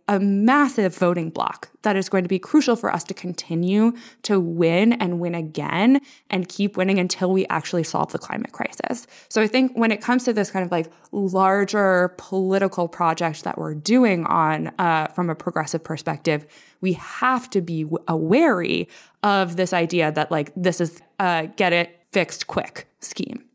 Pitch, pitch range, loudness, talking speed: 185 Hz, 170-205 Hz, -22 LUFS, 180 wpm